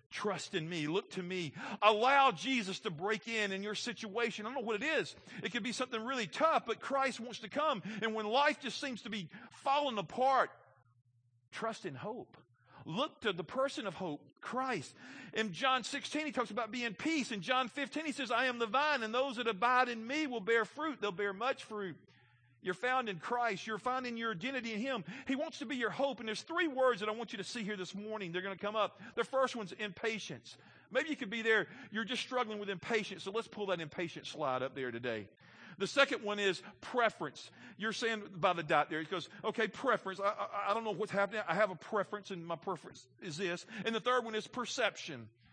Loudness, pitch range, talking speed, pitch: -36 LUFS, 190-250 Hz, 230 wpm, 220 Hz